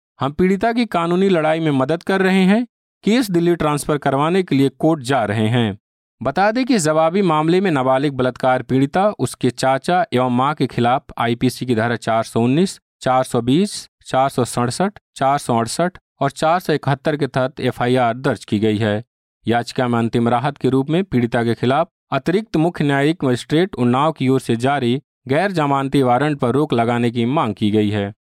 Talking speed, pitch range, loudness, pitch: 195 wpm, 120-160 Hz, -18 LUFS, 135 Hz